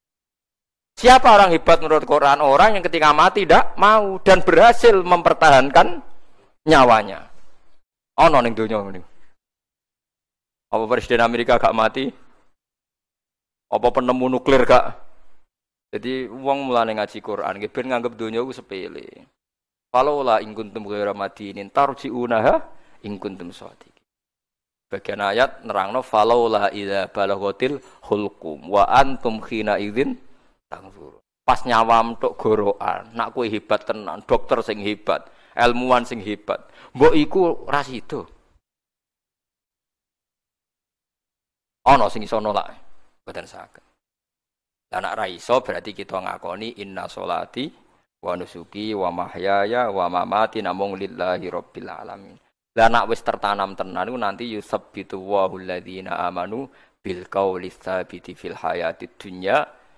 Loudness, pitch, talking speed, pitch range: -19 LUFS, 115 Hz, 110 wpm, 100-130 Hz